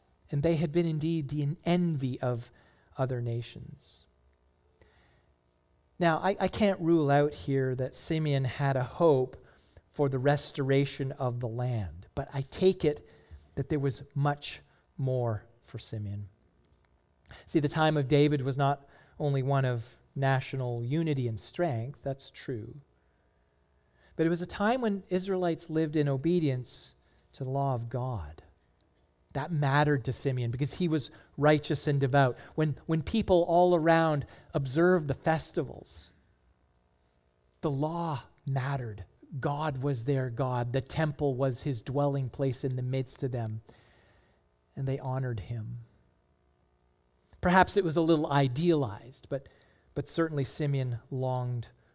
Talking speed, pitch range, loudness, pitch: 140 wpm, 110-150 Hz, -30 LUFS, 135 Hz